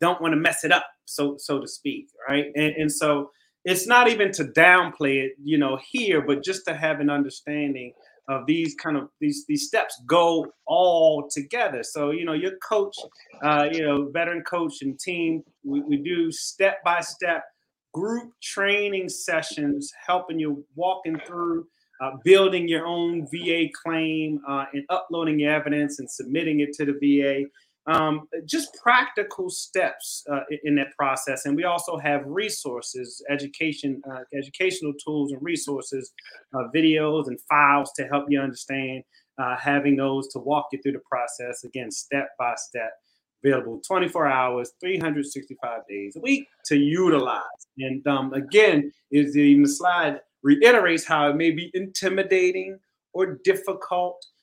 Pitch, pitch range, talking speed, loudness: 155 Hz, 140-180 Hz, 160 wpm, -23 LUFS